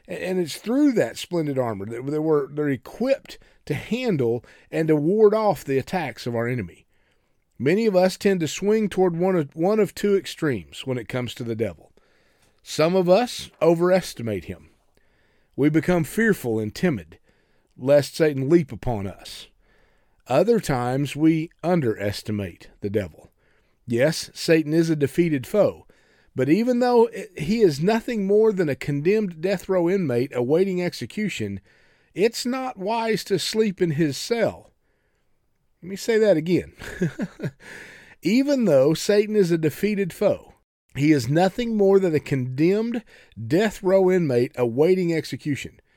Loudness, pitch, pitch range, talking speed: -22 LUFS, 165 Hz, 130-200 Hz, 145 wpm